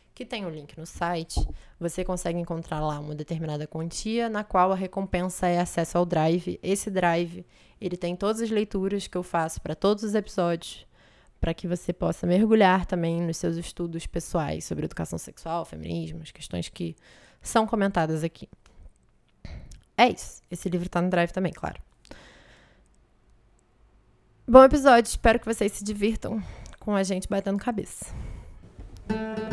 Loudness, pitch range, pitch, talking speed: -26 LUFS, 160-200 Hz, 175 Hz, 155 wpm